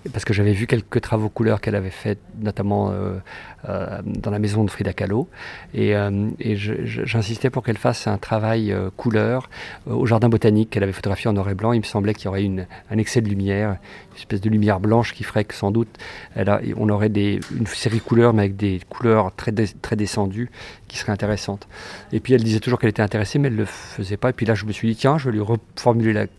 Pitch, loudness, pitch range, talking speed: 110 Hz, -21 LUFS, 100-115 Hz, 250 wpm